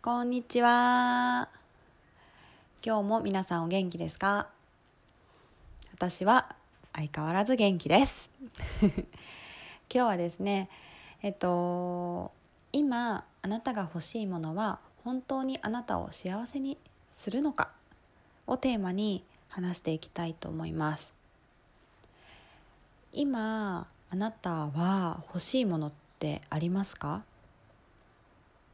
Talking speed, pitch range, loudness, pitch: 200 characters per minute, 170-240 Hz, -31 LUFS, 195 Hz